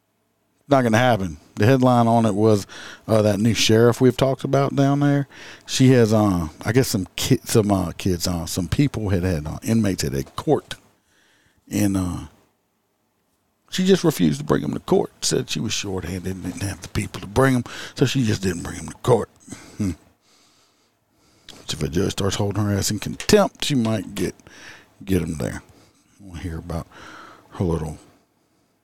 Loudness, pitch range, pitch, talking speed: -21 LUFS, 95-120 Hz, 105 Hz, 190 wpm